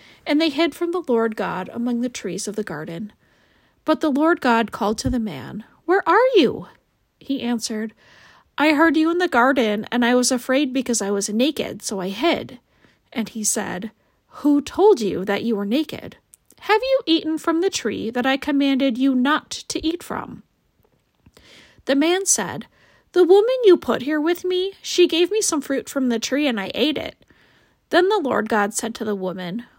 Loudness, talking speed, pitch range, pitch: -20 LUFS, 195 wpm, 225-335 Hz, 270 Hz